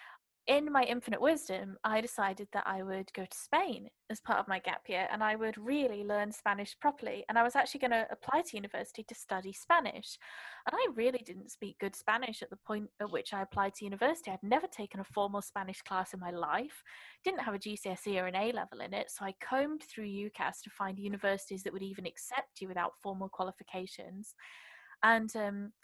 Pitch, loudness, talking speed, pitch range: 210 Hz, -35 LUFS, 210 wpm, 195-240 Hz